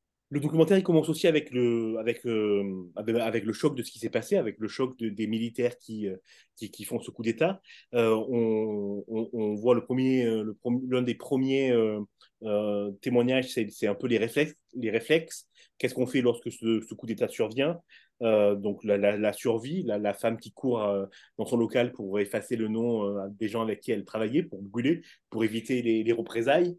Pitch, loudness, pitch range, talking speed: 115 Hz, -28 LUFS, 105-125 Hz, 215 wpm